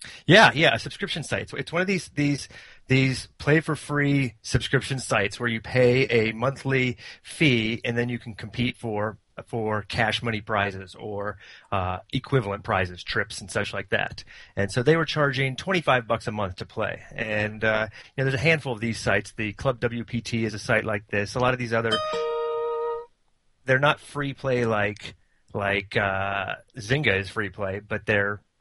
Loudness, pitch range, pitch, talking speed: -25 LUFS, 105-135 Hz, 120 Hz, 195 wpm